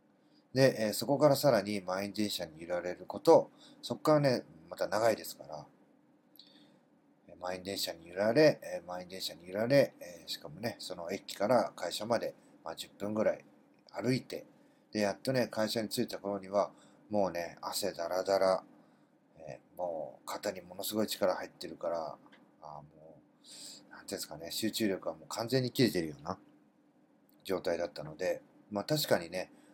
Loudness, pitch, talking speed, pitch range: -33 LUFS, 105 Hz, 315 characters per minute, 95-135 Hz